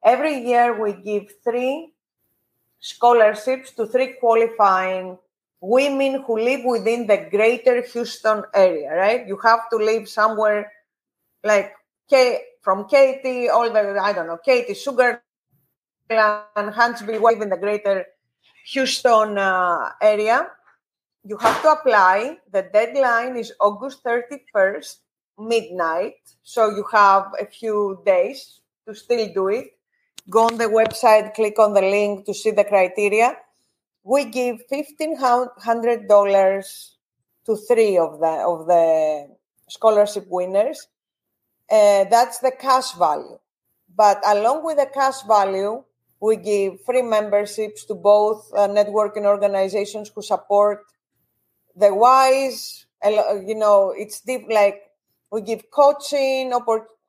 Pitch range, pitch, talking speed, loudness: 205-250 Hz, 220 Hz, 125 wpm, -19 LUFS